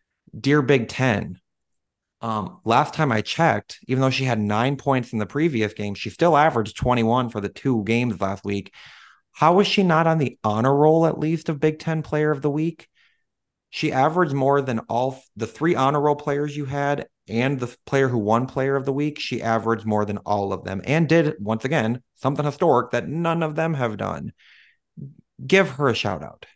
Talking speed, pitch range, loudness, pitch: 205 wpm, 115-155 Hz, -22 LUFS, 135 Hz